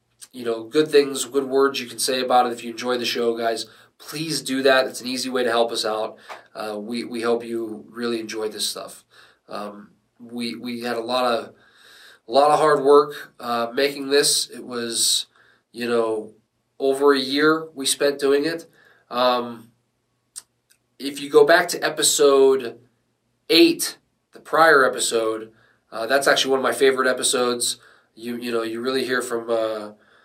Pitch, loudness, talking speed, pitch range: 120 Hz, -20 LUFS, 180 wpm, 115-140 Hz